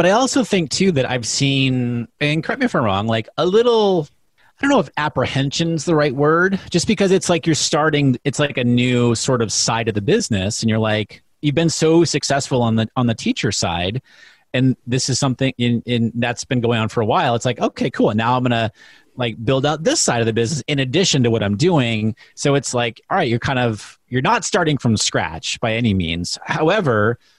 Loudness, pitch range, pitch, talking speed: -18 LUFS, 115-155 Hz, 130 Hz, 260 wpm